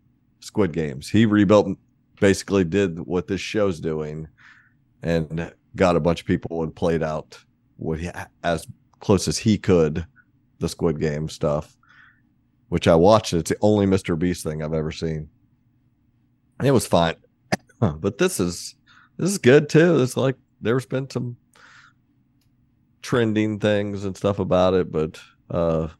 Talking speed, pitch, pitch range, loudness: 150 wpm, 100 Hz, 85-125 Hz, -22 LUFS